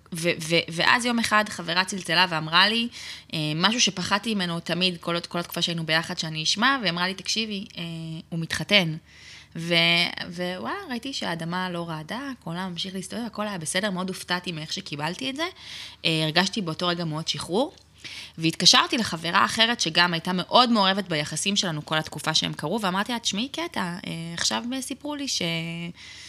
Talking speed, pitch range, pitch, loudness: 170 wpm, 165-210 Hz, 180 Hz, -24 LUFS